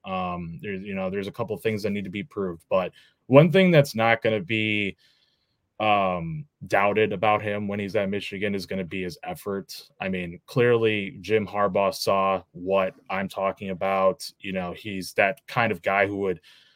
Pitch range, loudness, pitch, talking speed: 95-115 Hz, -25 LUFS, 100 Hz, 190 wpm